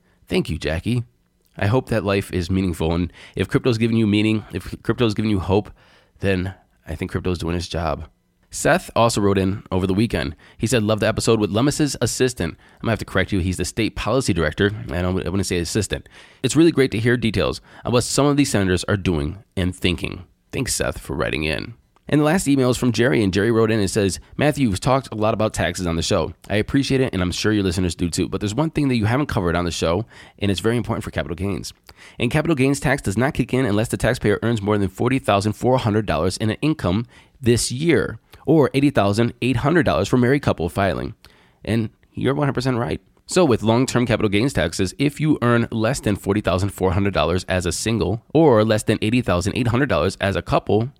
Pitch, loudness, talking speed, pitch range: 105 Hz, -20 LUFS, 215 wpm, 95-120 Hz